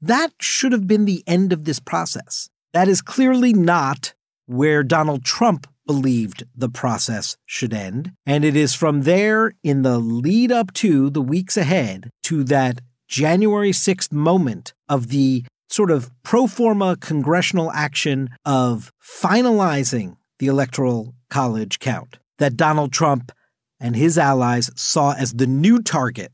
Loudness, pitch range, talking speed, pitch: -19 LUFS, 130-185 Hz, 145 wpm, 145 Hz